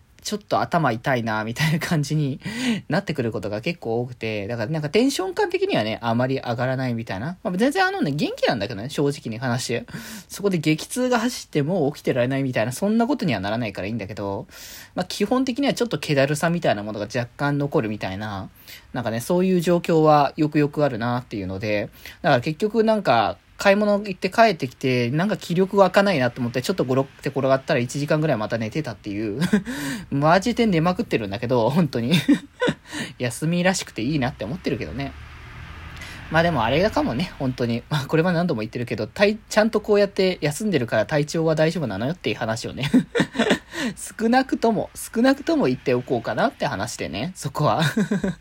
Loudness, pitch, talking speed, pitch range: -22 LUFS, 150 Hz, 435 characters per minute, 120-200 Hz